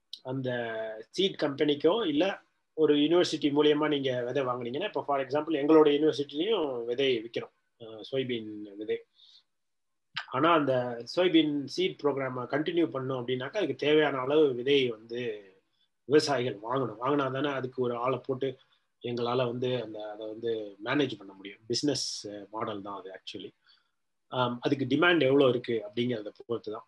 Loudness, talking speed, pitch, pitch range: -29 LUFS, 135 wpm, 130 Hz, 120-150 Hz